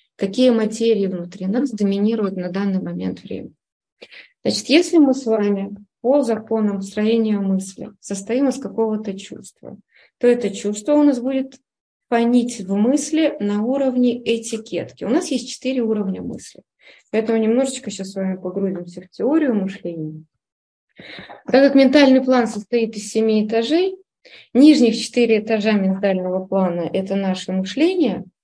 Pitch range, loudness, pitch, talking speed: 195-255 Hz, -19 LUFS, 220 Hz, 135 wpm